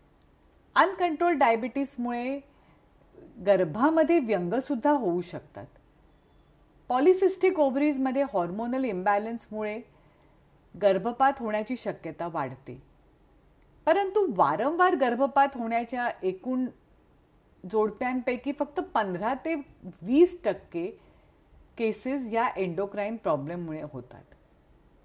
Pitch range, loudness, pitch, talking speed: 200-290 Hz, -27 LUFS, 245 Hz, 70 wpm